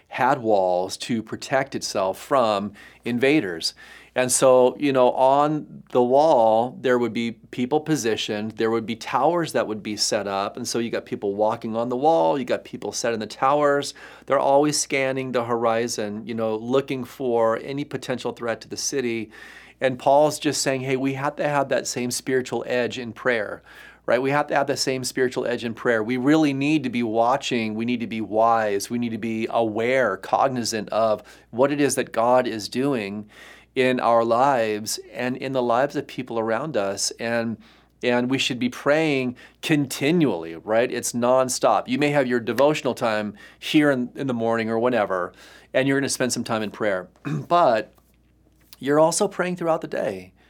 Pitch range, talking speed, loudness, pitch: 115-140 Hz, 190 wpm, -22 LUFS, 125 Hz